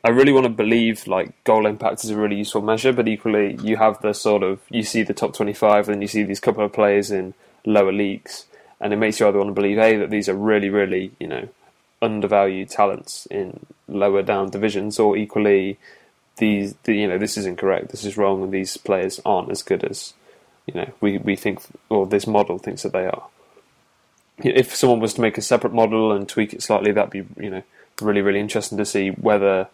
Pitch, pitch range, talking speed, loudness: 105 Hz, 100-110 Hz, 225 wpm, -20 LUFS